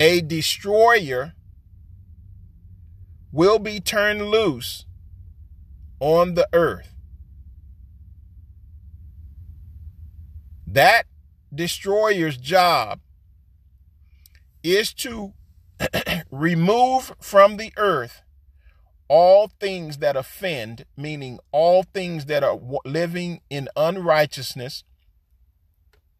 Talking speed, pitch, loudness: 70 wpm, 95 Hz, -20 LUFS